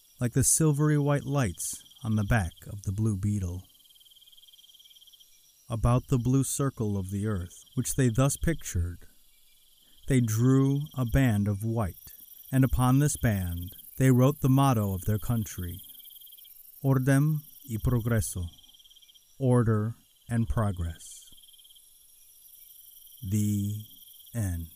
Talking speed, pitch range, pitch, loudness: 115 wpm, 90-130 Hz, 110 Hz, -28 LUFS